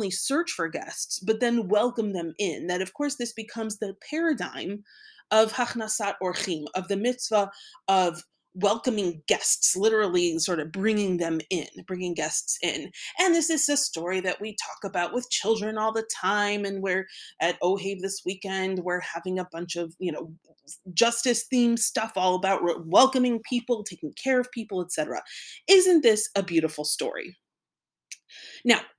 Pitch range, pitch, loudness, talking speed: 180-240 Hz, 200 Hz, -26 LUFS, 160 wpm